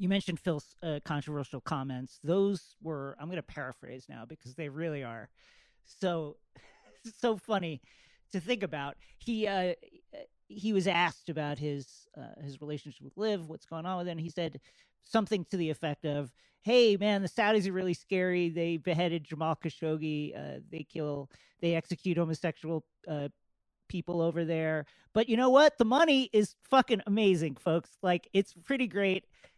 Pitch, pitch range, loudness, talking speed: 170 Hz, 150-200 Hz, -32 LUFS, 165 wpm